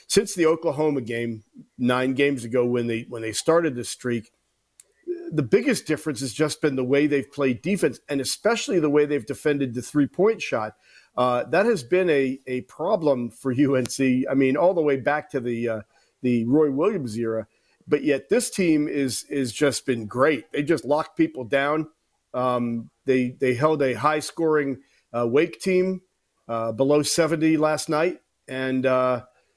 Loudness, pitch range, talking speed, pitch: -23 LUFS, 125-155 Hz, 180 wpm, 140 Hz